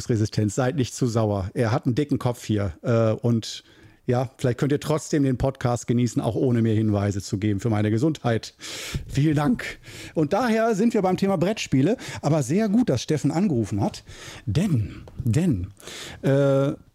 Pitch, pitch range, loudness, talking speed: 125 Hz, 110-150 Hz, -24 LUFS, 170 wpm